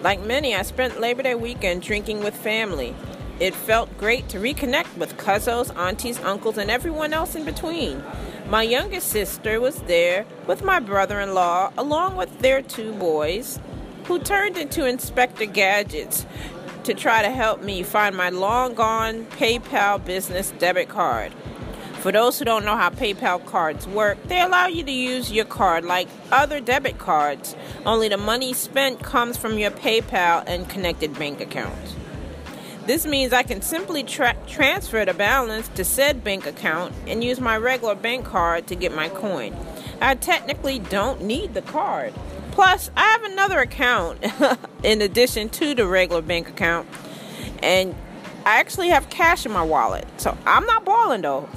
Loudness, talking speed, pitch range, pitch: -21 LUFS, 165 wpm, 195-270 Hz, 225 Hz